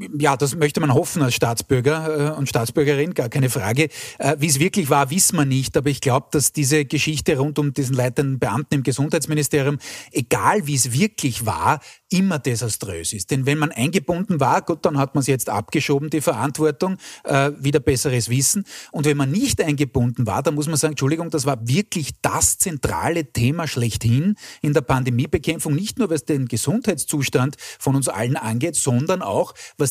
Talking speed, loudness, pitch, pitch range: 180 wpm, -20 LUFS, 145 Hz, 135-160 Hz